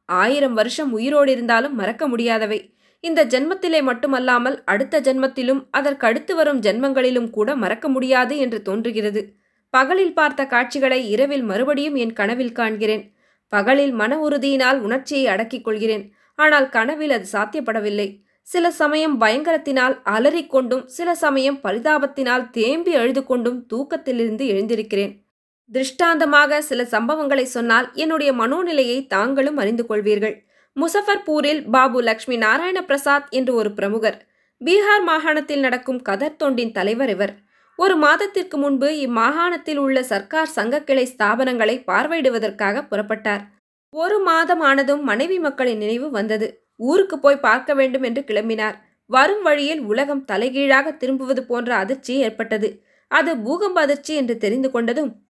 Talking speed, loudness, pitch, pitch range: 120 wpm, -19 LUFS, 260 Hz, 225-290 Hz